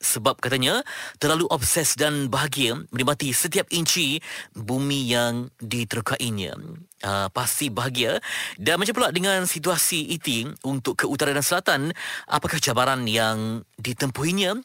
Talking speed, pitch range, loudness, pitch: 125 wpm, 120-165 Hz, -23 LUFS, 140 Hz